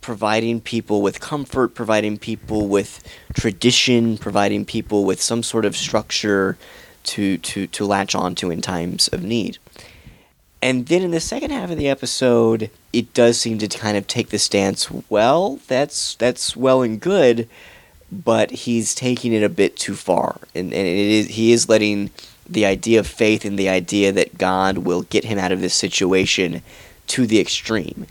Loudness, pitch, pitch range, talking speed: -19 LUFS, 110 Hz, 100-120 Hz, 175 wpm